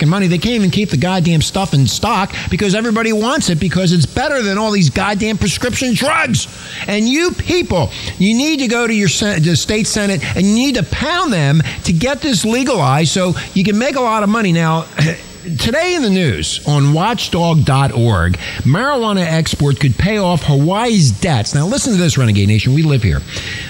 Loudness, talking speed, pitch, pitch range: -14 LUFS, 200 wpm, 180 Hz, 145-220 Hz